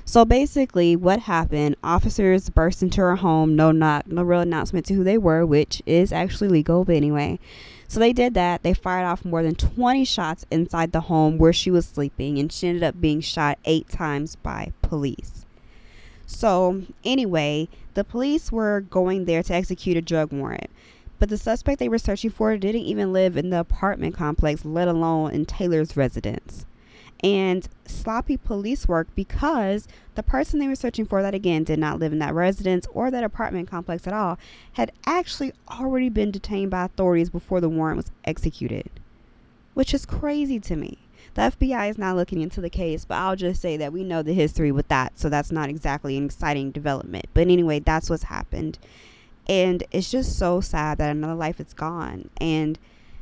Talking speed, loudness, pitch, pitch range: 190 wpm, -23 LUFS, 175 Hz, 155-200 Hz